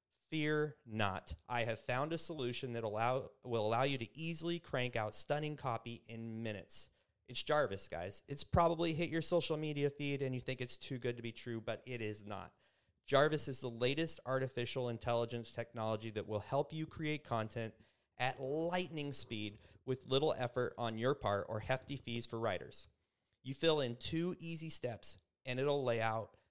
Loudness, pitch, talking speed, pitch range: -39 LUFS, 125 Hz, 180 wpm, 115-145 Hz